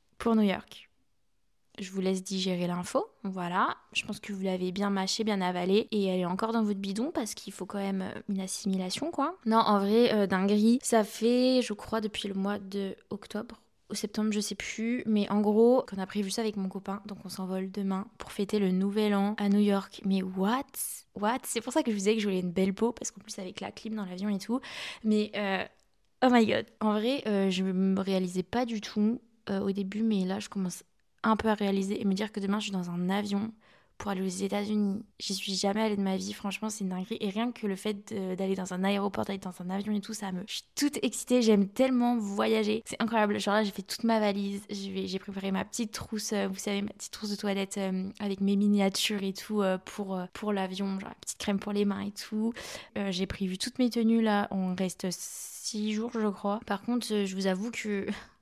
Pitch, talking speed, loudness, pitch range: 205 Hz, 235 wpm, -30 LUFS, 195-220 Hz